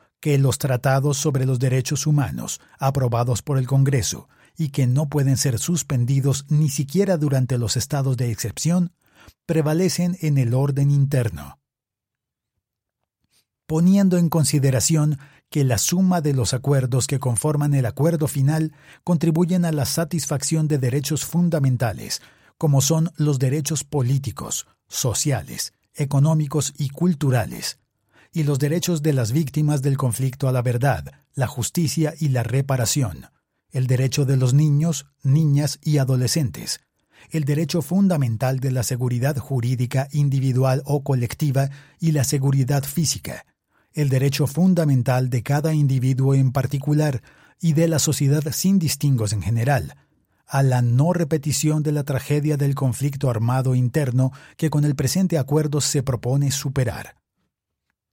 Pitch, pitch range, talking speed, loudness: 140 Hz, 130-155 Hz, 135 wpm, -21 LUFS